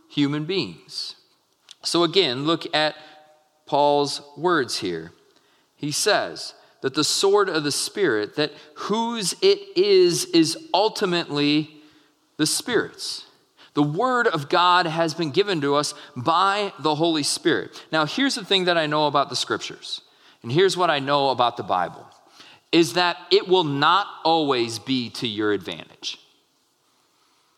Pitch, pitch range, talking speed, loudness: 160 Hz, 145-195 Hz, 145 wpm, -22 LUFS